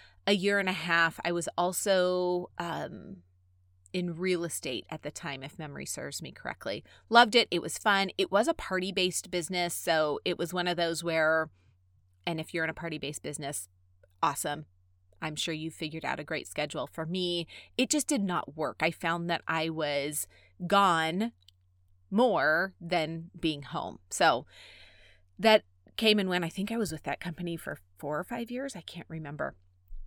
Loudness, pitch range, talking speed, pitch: -30 LUFS, 140-185 Hz, 185 wpm, 165 Hz